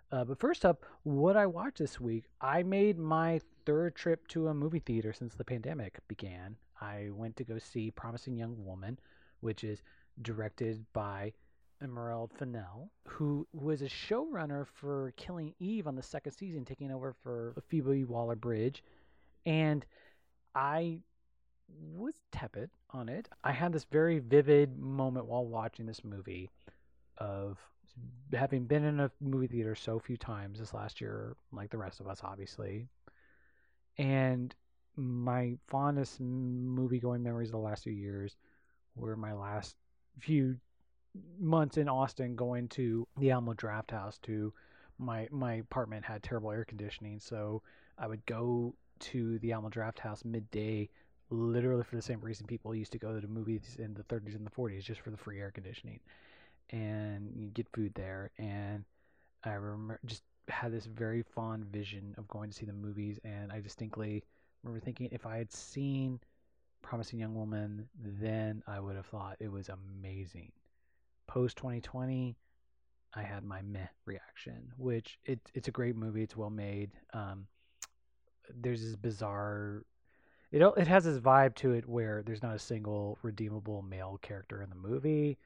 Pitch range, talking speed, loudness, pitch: 105-130 Hz, 165 wpm, -37 LUFS, 115 Hz